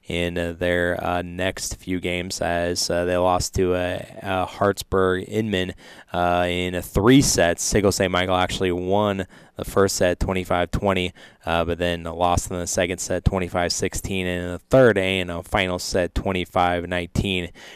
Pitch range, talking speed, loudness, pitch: 90-95 Hz, 160 wpm, -22 LUFS, 90 Hz